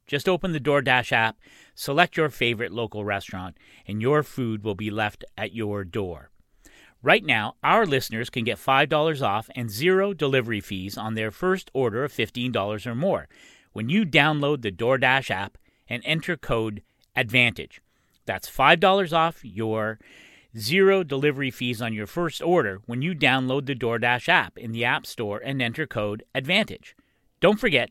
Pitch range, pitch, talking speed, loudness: 110-150 Hz, 125 Hz, 165 wpm, -24 LUFS